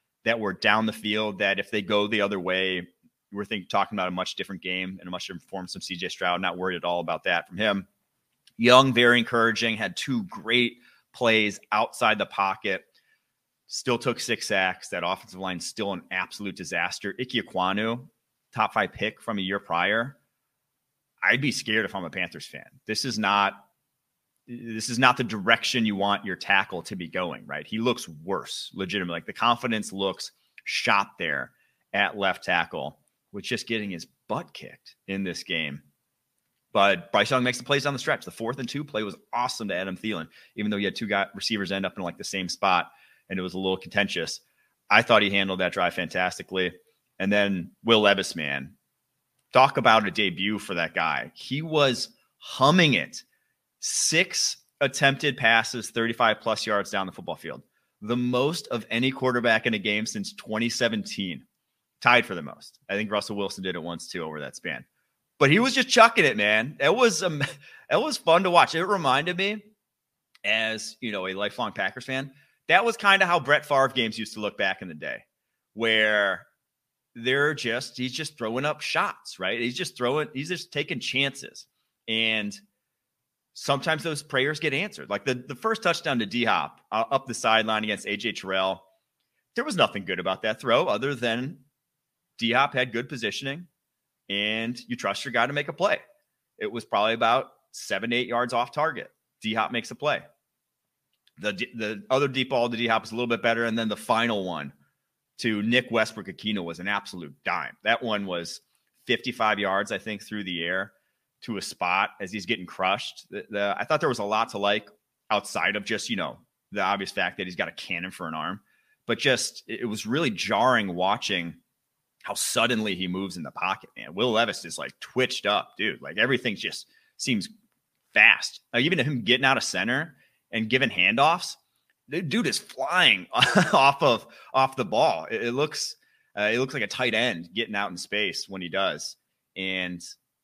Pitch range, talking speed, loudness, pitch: 100-130 Hz, 195 wpm, -25 LUFS, 115 Hz